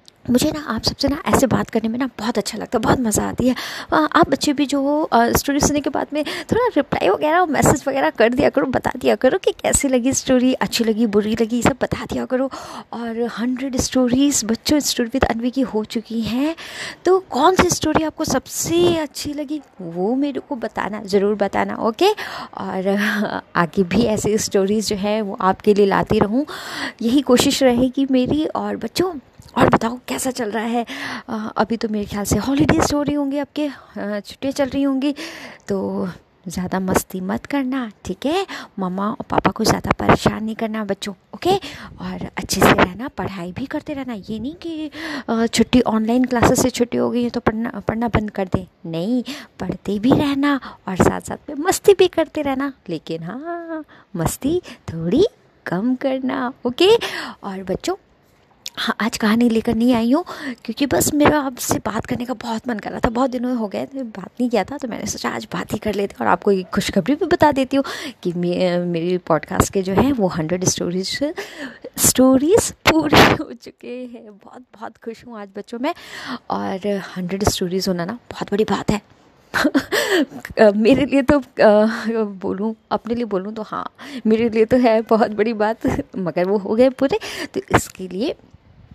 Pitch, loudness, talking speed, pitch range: 245 Hz, -19 LUFS, 190 wpm, 210-285 Hz